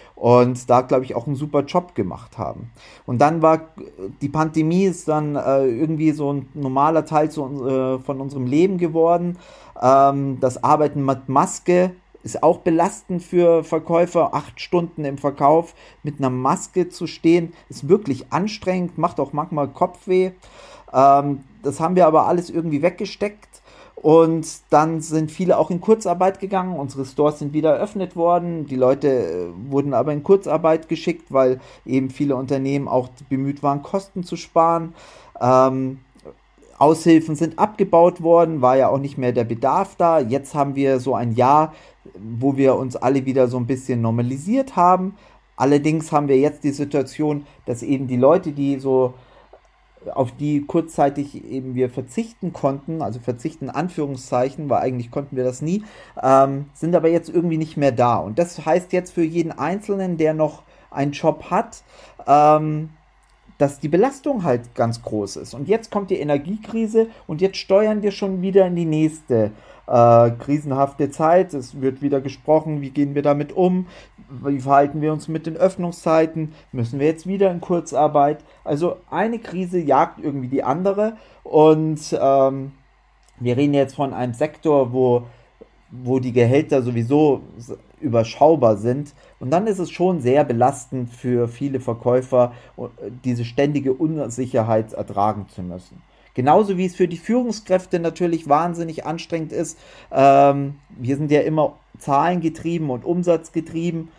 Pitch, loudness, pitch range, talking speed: 150 Hz, -19 LUFS, 135-170 Hz, 160 wpm